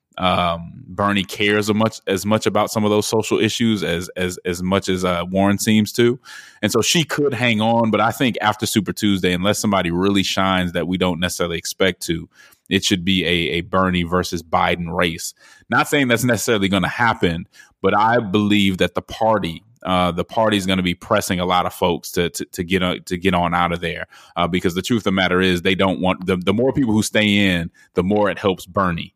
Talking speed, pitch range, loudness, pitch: 230 wpm, 90-105 Hz, -19 LUFS, 95 Hz